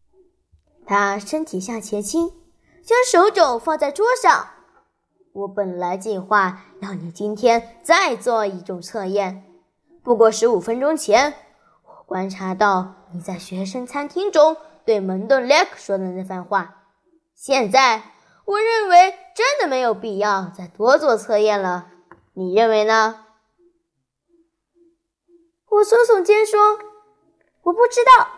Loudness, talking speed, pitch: -18 LUFS, 180 characters per minute, 235 Hz